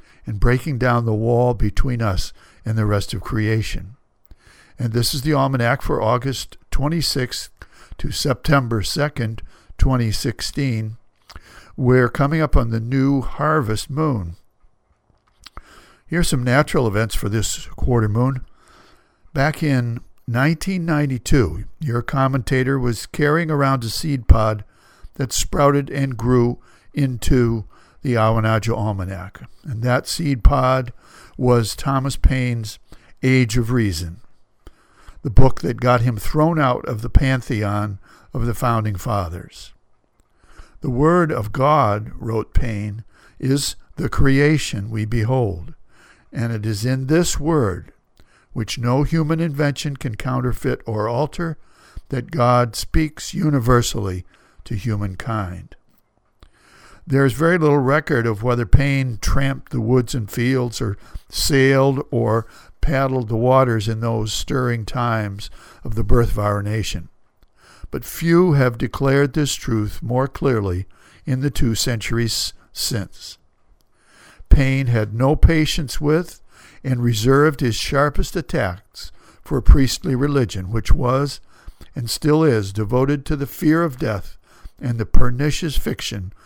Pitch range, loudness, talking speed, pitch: 110-140 Hz, -20 LUFS, 130 wpm, 125 Hz